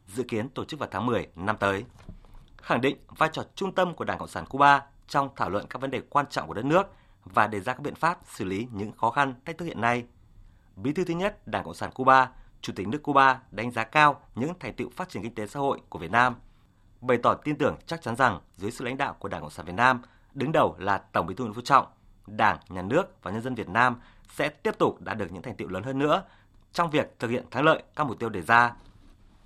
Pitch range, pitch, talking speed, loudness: 100-135 Hz, 120 Hz, 265 wpm, -27 LUFS